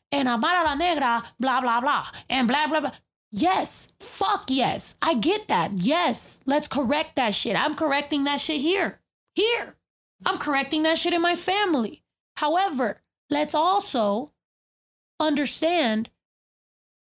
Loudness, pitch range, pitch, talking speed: -24 LUFS, 255-345 Hz, 295 Hz, 135 wpm